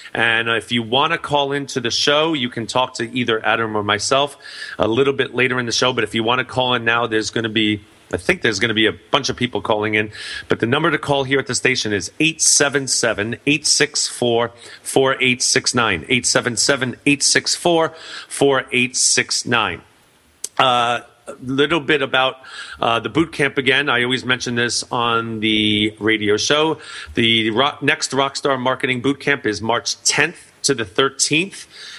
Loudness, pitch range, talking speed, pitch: -17 LUFS, 115-140 Hz, 180 wpm, 125 Hz